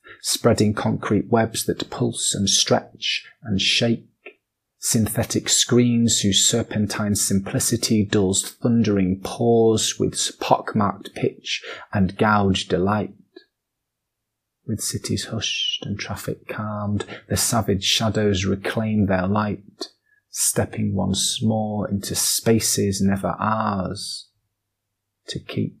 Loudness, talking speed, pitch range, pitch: -21 LUFS, 100 wpm, 100-110 Hz, 105 Hz